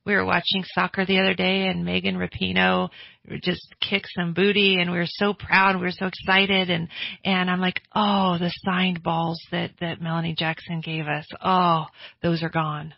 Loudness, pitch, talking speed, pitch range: -23 LUFS, 175 Hz, 190 wpm, 165-190 Hz